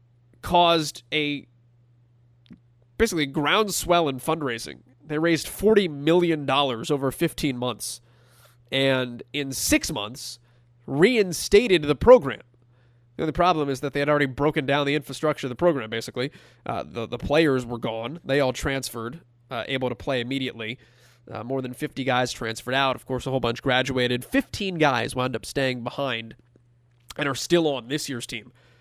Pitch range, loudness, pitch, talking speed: 120-150 Hz, -24 LUFS, 130 Hz, 160 wpm